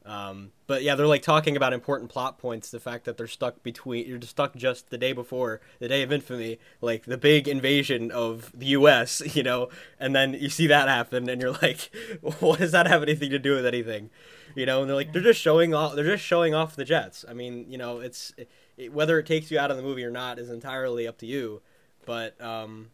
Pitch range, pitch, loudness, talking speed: 120-145 Hz, 130 Hz, -25 LUFS, 245 wpm